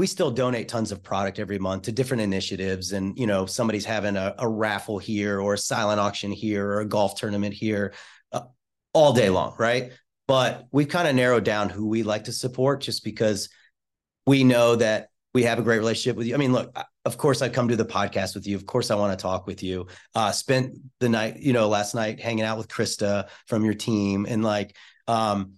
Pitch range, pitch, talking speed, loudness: 100-120 Hz, 110 Hz, 225 wpm, -24 LUFS